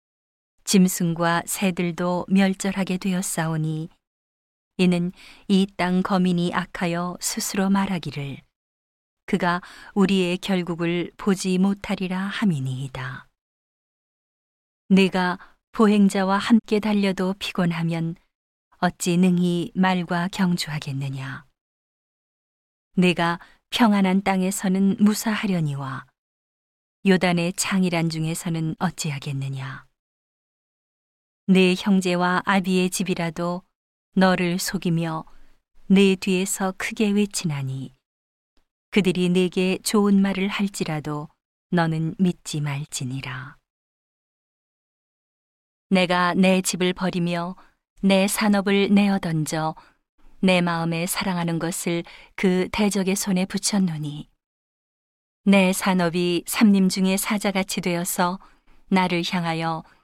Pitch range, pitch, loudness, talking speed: 165-195 Hz, 180 Hz, -22 LUFS, 210 characters per minute